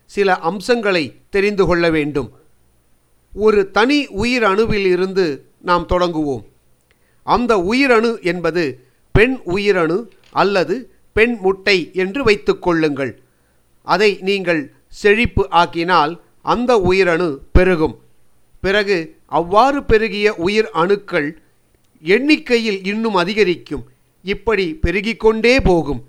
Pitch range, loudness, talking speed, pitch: 165-215 Hz, -16 LUFS, 90 wpm, 190 Hz